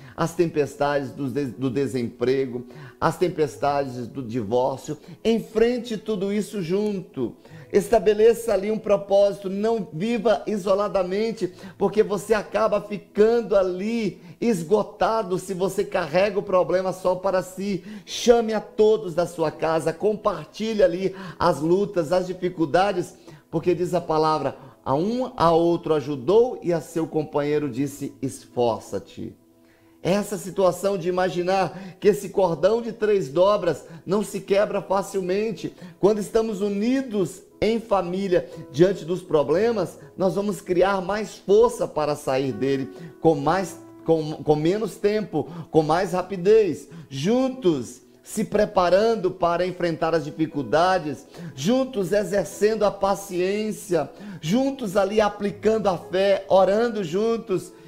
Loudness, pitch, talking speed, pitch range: -23 LUFS, 185 Hz, 125 wpm, 160-205 Hz